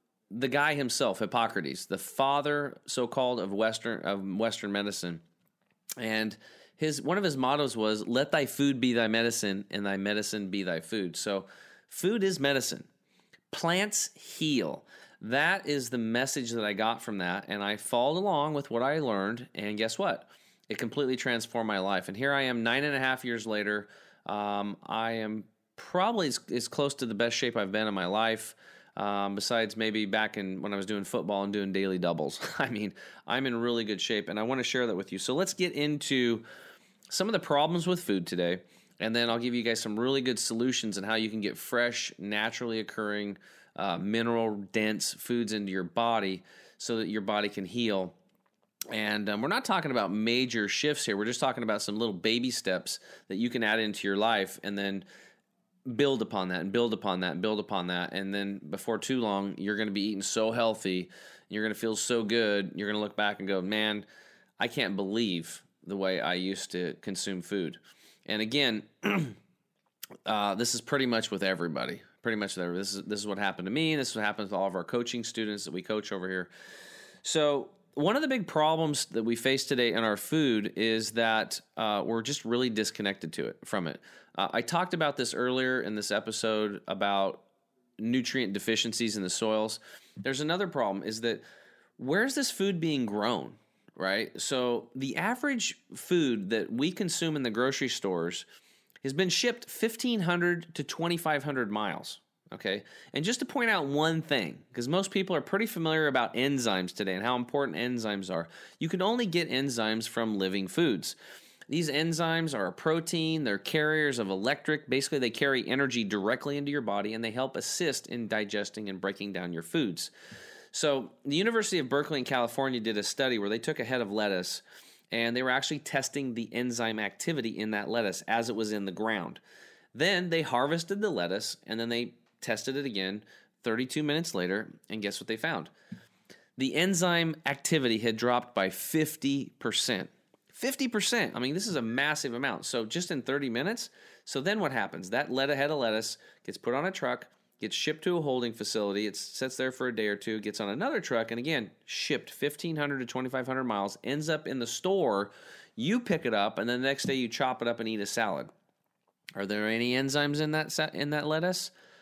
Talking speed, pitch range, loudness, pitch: 200 wpm, 105-140 Hz, -31 LUFS, 115 Hz